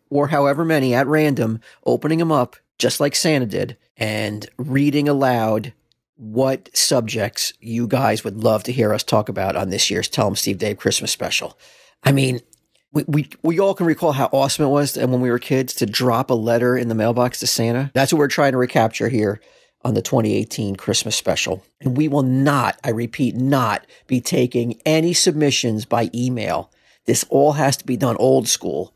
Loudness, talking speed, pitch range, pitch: -19 LUFS, 195 wpm, 115-140 Hz, 125 Hz